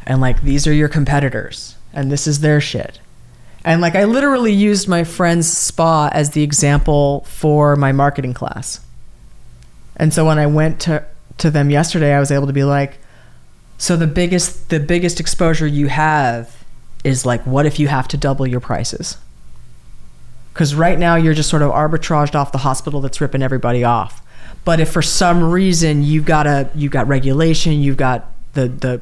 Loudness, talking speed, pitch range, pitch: -15 LUFS, 185 wpm, 130-160 Hz, 145 Hz